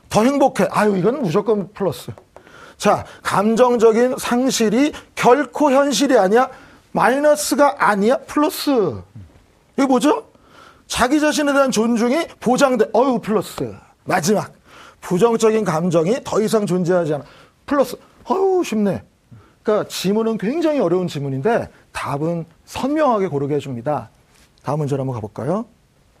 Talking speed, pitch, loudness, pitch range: 295 characters per minute, 220 Hz, -18 LUFS, 175-270 Hz